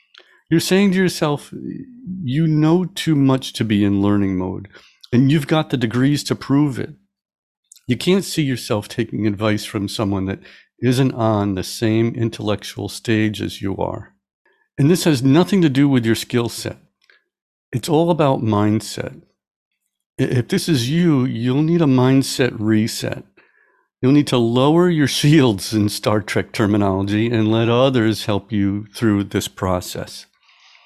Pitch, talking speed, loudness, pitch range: 120 Hz, 155 wpm, -18 LUFS, 105-145 Hz